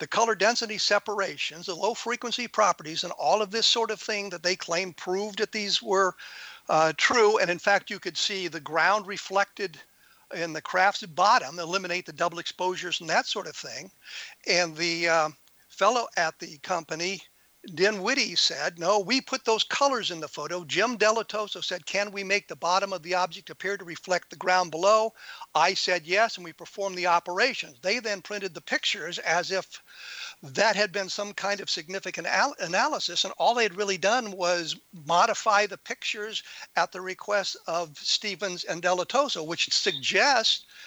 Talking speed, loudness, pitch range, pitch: 180 wpm, -26 LUFS, 175-210 Hz, 190 Hz